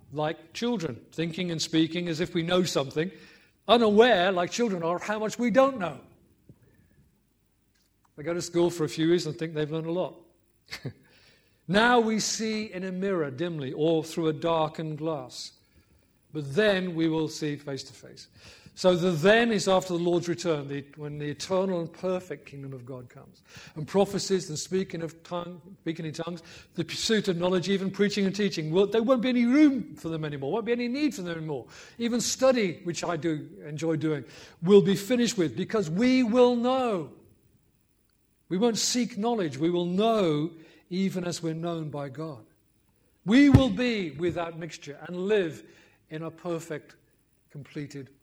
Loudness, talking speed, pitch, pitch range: -27 LUFS, 180 wpm, 170 Hz, 155-195 Hz